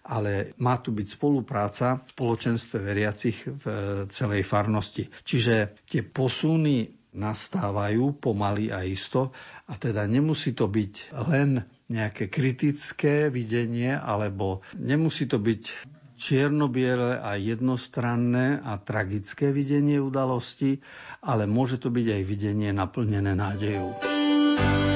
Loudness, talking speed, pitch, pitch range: -26 LUFS, 110 wpm, 120 Hz, 105-135 Hz